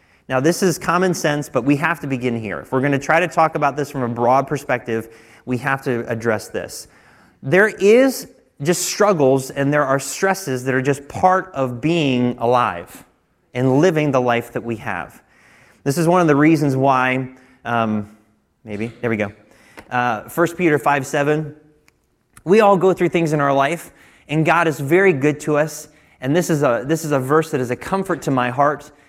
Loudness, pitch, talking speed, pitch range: -18 LUFS, 145 Hz, 200 wpm, 125-160 Hz